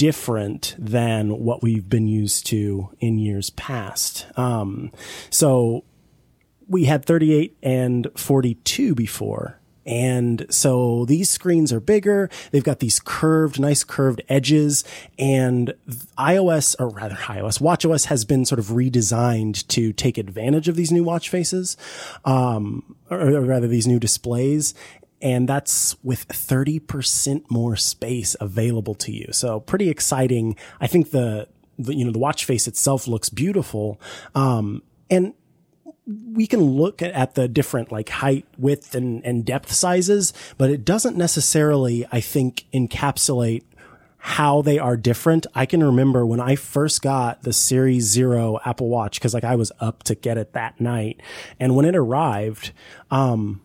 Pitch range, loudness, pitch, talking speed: 115-145 Hz, -20 LUFS, 130 Hz, 150 wpm